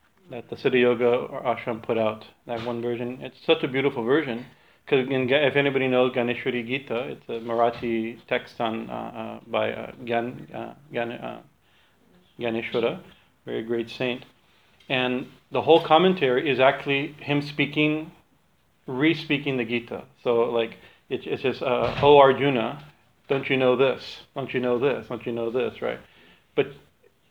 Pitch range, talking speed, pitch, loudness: 120-140 Hz, 155 wpm, 125 Hz, -24 LUFS